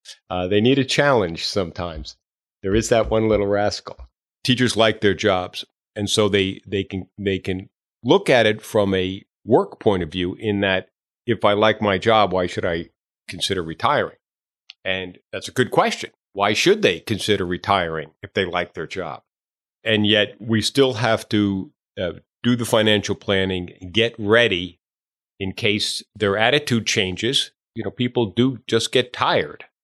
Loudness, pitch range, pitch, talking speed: -20 LUFS, 95-110 Hz, 100 Hz, 170 wpm